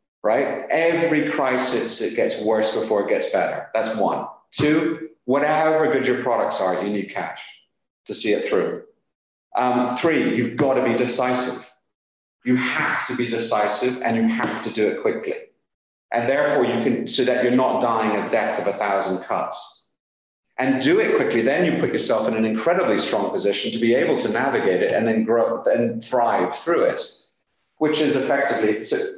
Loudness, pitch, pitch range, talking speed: -21 LUFS, 130 Hz, 115-165 Hz, 185 wpm